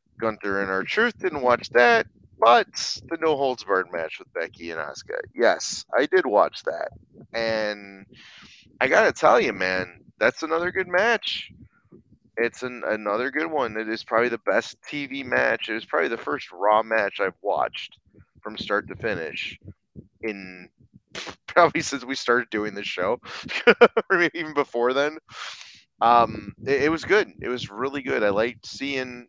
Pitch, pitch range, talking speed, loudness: 120 Hz, 105-145 Hz, 165 wpm, -23 LUFS